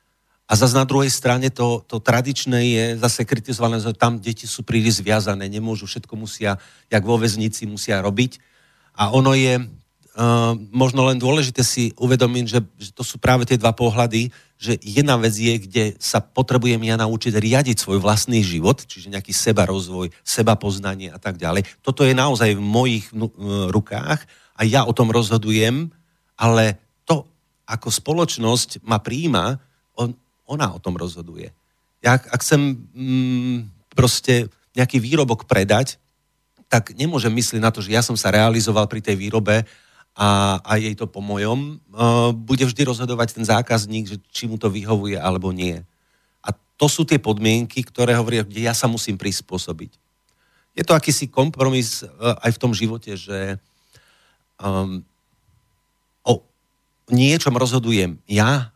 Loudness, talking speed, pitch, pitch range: -19 LUFS, 155 wpm, 115 Hz, 105-125 Hz